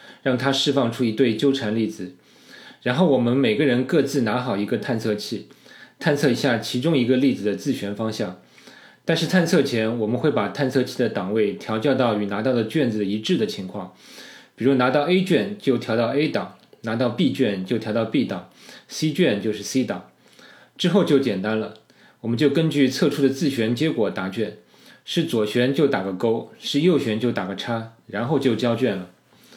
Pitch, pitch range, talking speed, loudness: 120 Hz, 110-140 Hz, 280 characters per minute, -22 LUFS